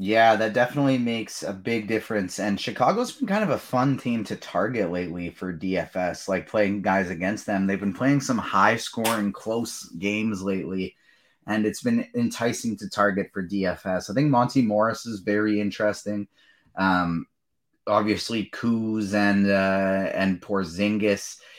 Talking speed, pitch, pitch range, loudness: 155 wpm, 105 Hz, 95-115 Hz, -25 LUFS